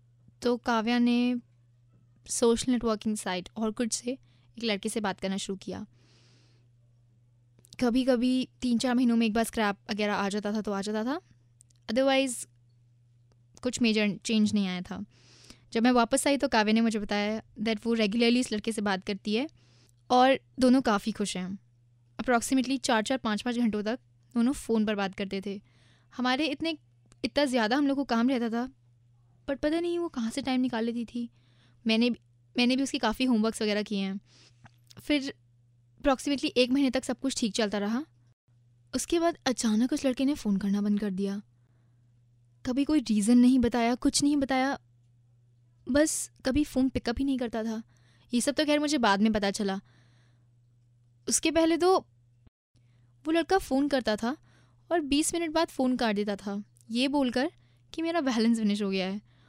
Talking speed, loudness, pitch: 180 wpm, -28 LUFS, 220 Hz